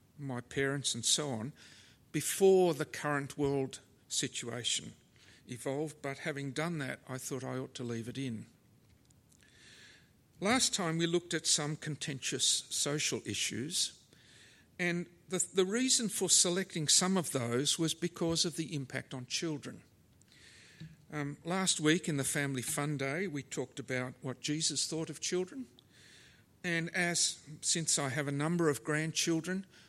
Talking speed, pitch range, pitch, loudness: 145 wpm, 135-170 Hz, 150 Hz, -33 LUFS